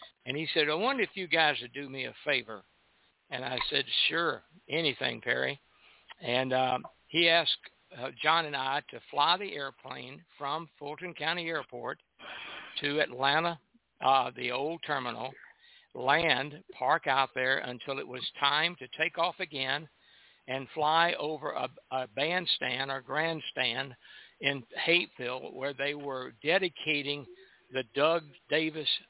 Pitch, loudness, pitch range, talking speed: 145 Hz, -30 LUFS, 130-160 Hz, 145 wpm